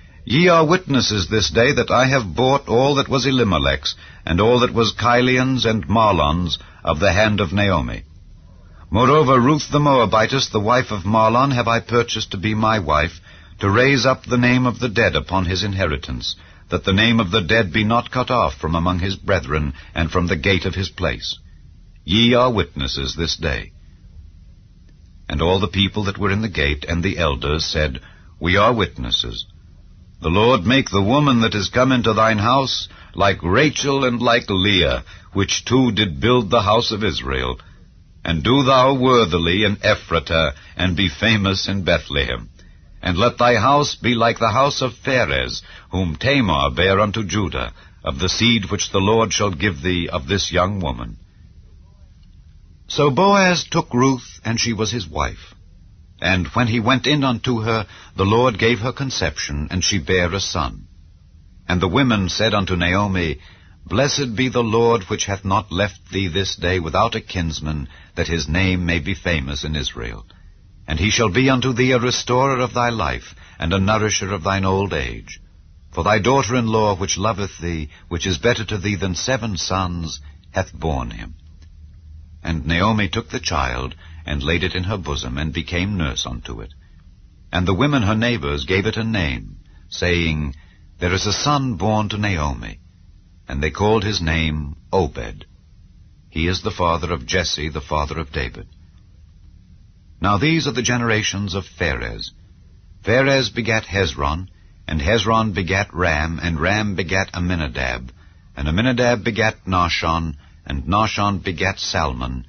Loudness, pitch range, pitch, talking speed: -18 LUFS, 85-110 Hz, 95 Hz, 170 wpm